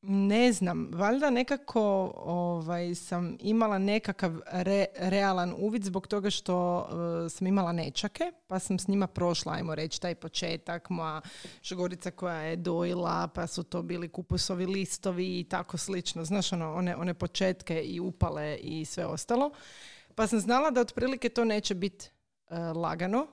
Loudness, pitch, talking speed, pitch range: -31 LUFS, 180 Hz, 155 wpm, 175-200 Hz